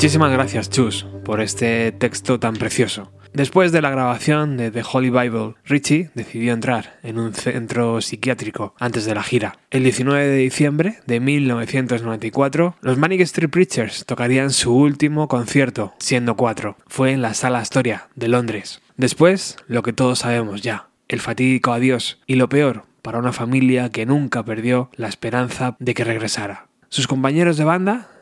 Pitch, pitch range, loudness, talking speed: 125 Hz, 115-135 Hz, -19 LUFS, 165 wpm